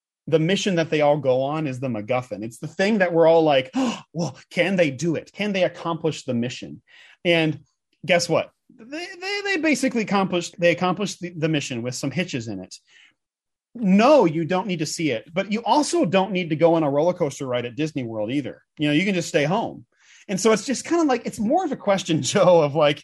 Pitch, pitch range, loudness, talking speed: 170 Hz, 150-200 Hz, -22 LUFS, 235 wpm